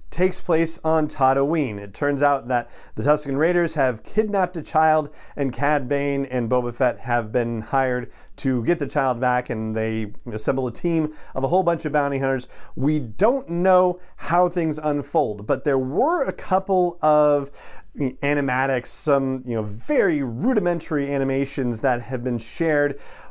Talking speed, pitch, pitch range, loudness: 165 wpm, 140 Hz, 125-160 Hz, -22 LUFS